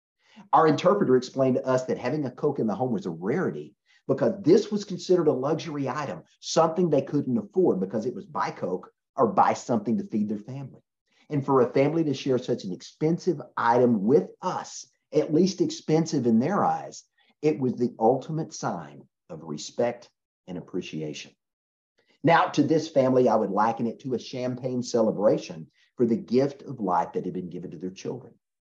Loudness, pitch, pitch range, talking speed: -25 LUFS, 135 Hz, 120-155 Hz, 185 wpm